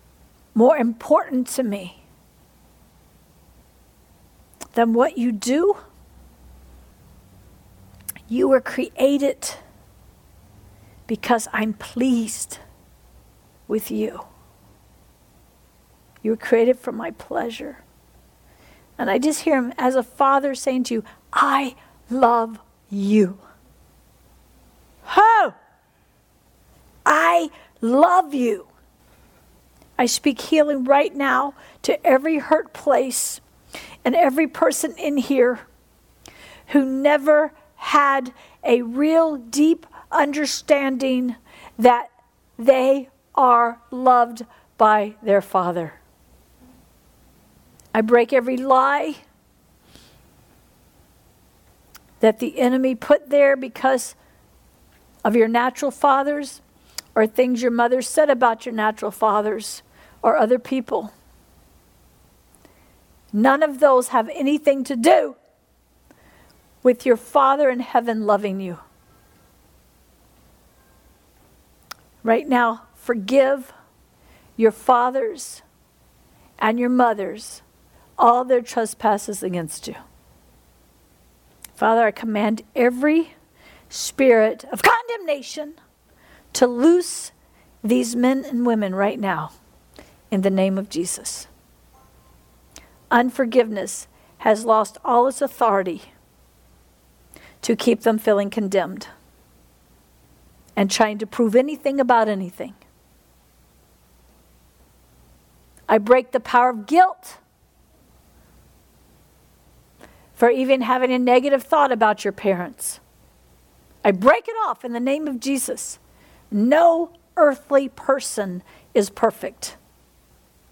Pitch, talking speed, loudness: 235 Hz, 95 wpm, -20 LUFS